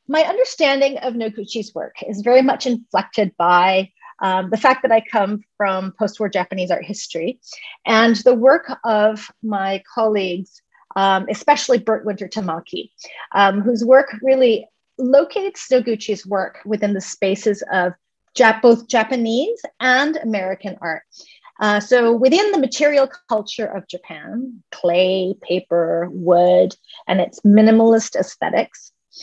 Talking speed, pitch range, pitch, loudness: 135 wpm, 195-255 Hz, 220 Hz, -17 LUFS